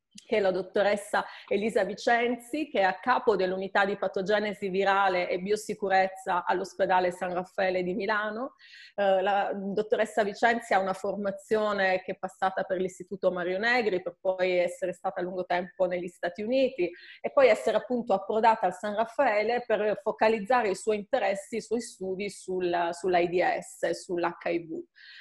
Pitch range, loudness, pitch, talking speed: 185-215 Hz, -28 LUFS, 195 Hz, 150 wpm